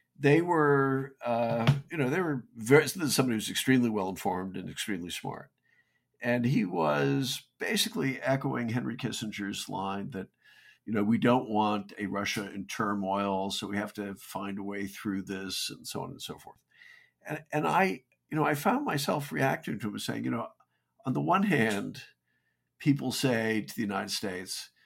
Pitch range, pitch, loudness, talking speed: 100-135 Hz, 115 Hz, -30 LUFS, 175 wpm